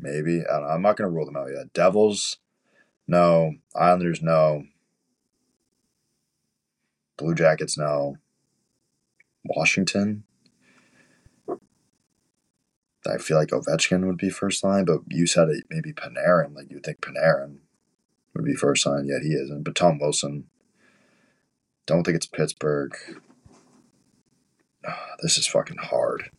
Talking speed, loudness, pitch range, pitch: 125 wpm, -23 LUFS, 75-95 Hz, 80 Hz